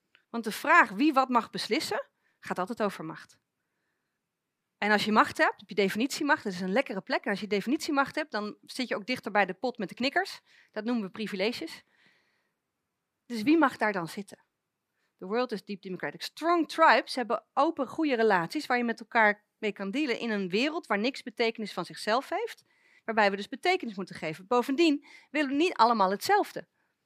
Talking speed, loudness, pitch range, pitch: 195 wpm, -28 LUFS, 205-300 Hz, 235 Hz